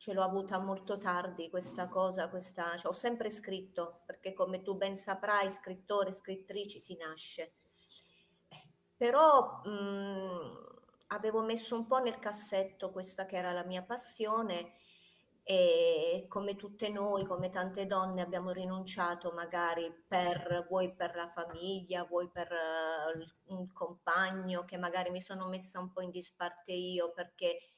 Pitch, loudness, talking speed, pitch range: 185 Hz, -35 LUFS, 145 wpm, 175-205 Hz